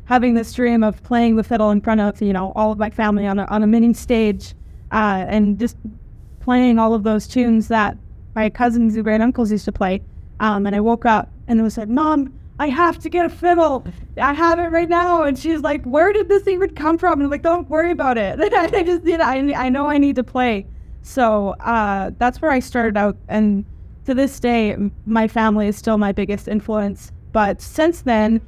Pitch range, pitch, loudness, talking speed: 215-285 Hz, 230 Hz, -18 LUFS, 230 wpm